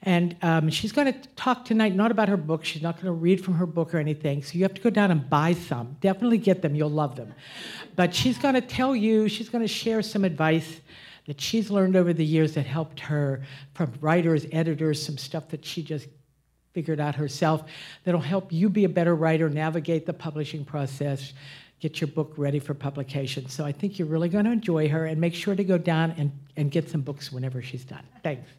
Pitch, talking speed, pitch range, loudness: 160 Hz, 220 wpm, 150-185 Hz, -26 LUFS